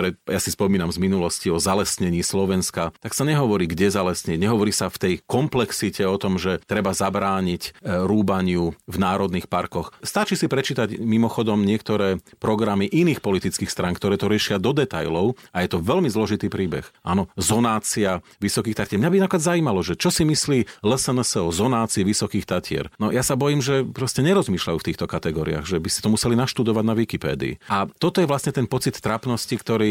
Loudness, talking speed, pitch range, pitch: -22 LUFS, 180 wpm, 95-125 Hz, 105 Hz